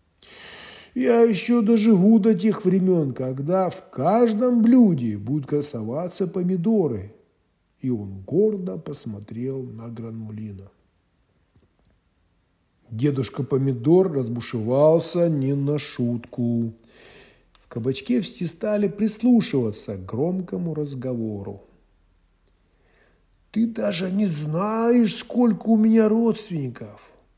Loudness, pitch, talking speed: -22 LUFS, 145 Hz, 90 wpm